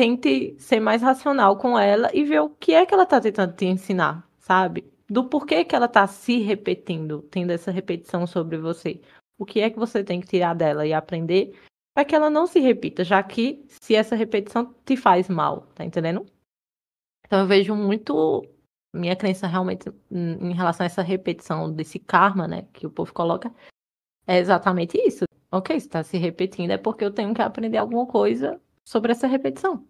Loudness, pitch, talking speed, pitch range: -22 LUFS, 200 Hz, 190 wpm, 180-240 Hz